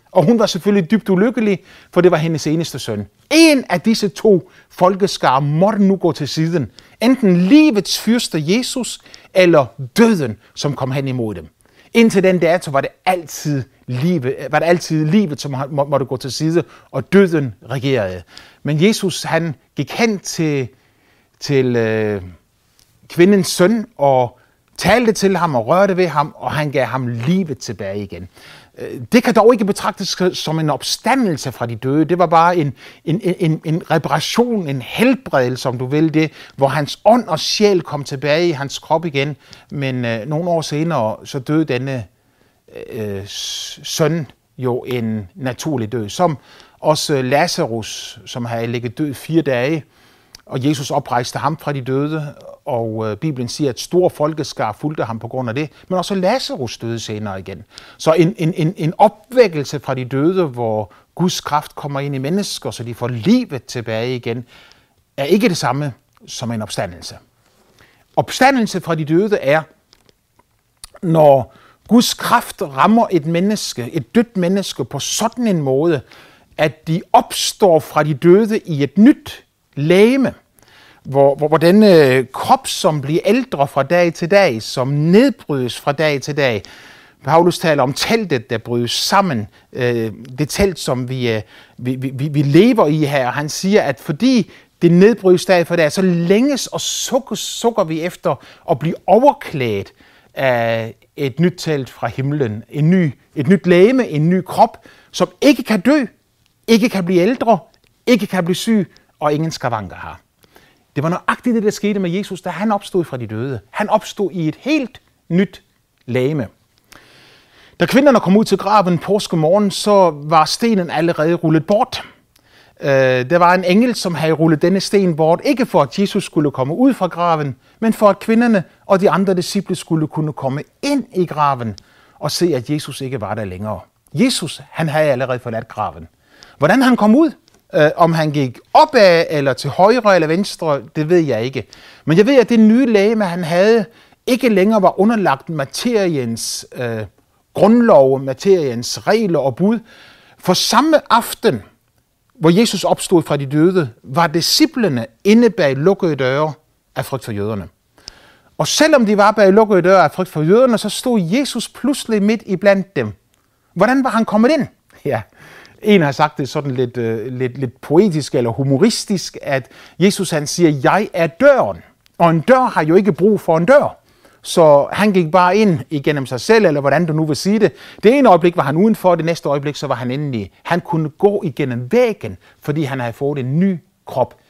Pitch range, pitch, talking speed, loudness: 135-195 Hz, 160 Hz, 175 wpm, -15 LUFS